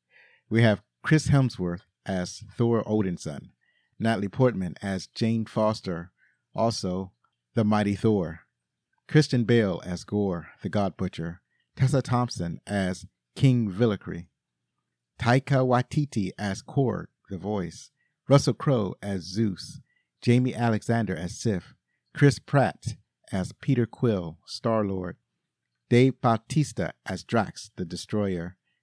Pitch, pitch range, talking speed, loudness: 105 Hz, 95-120 Hz, 115 wpm, -26 LUFS